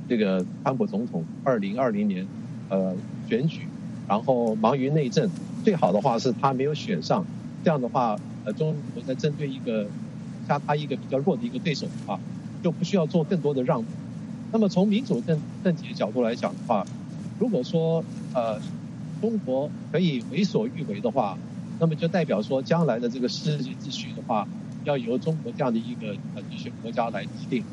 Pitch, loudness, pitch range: 165 Hz, -27 LUFS, 145-210 Hz